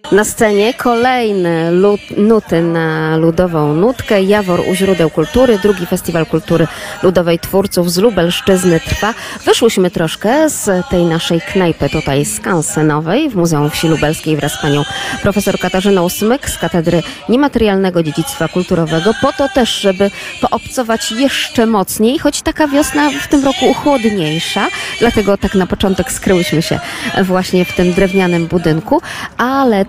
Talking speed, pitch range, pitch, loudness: 140 wpm, 165-220 Hz, 185 Hz, -13 LUFS